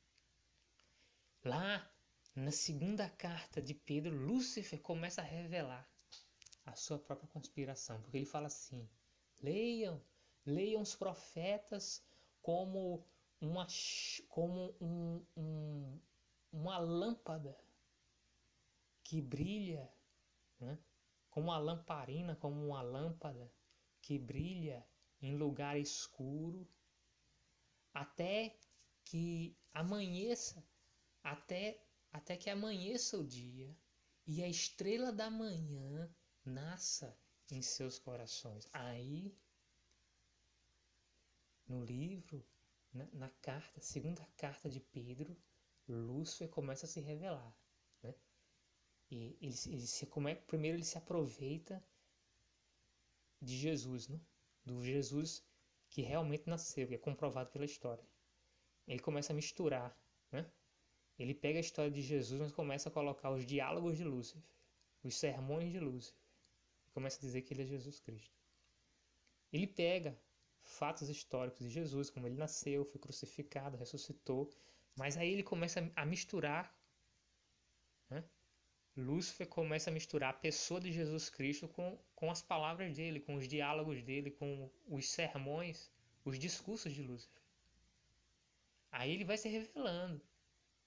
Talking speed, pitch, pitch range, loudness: 120 wpm, 150 Hz, 130-170 Hz, -44 LUFS